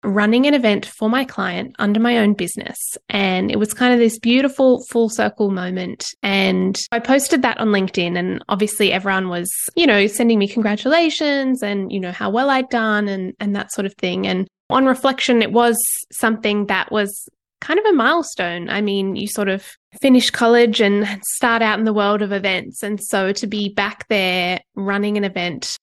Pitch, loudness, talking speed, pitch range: 210 Hz, -18 LUFS, 195 wpm, 195-240 Hz